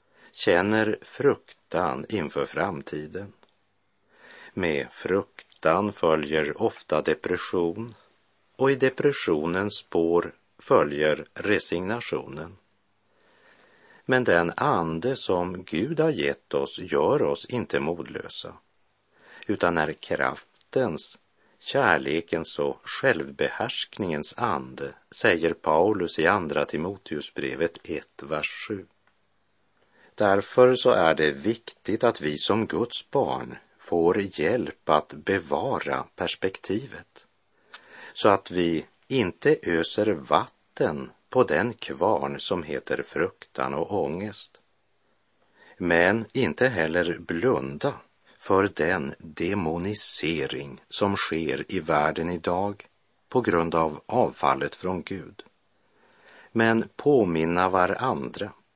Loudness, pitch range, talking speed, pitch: -26 LUFS, 80-105 Hz, 95 wpm, 90 Hz